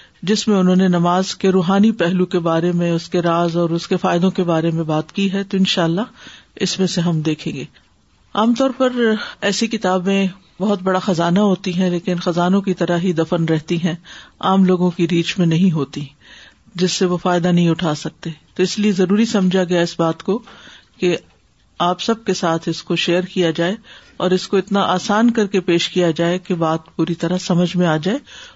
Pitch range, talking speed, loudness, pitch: 170-195 Hz, 215 wpm, -18 LUFS, 180 Hz